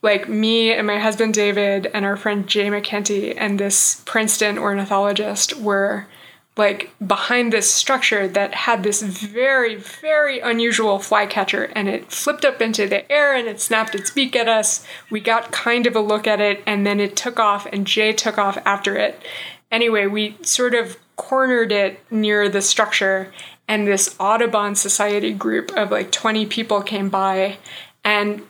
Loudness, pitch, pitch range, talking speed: -18 LUFS, 210 Hz, 200-225 Hz, 170 wpm